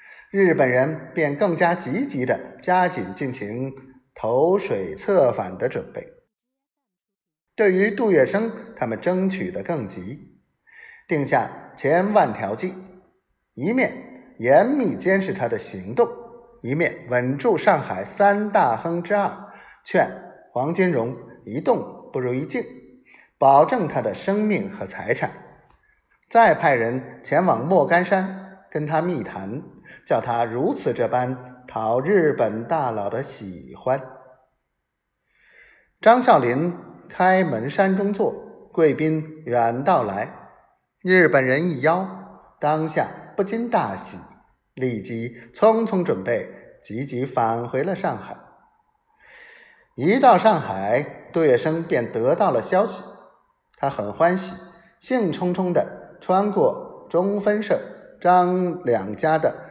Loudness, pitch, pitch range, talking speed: -21 LUFS, 180 Hz, 135-210 Hz, 170 characters per minute